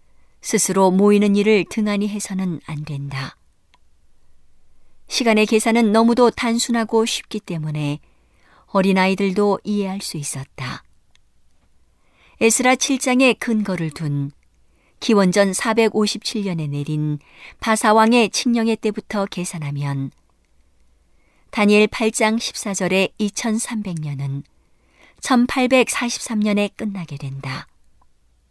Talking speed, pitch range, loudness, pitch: 195 characters per minute, 140-220 Hz, -19 LUFS, 195 Hz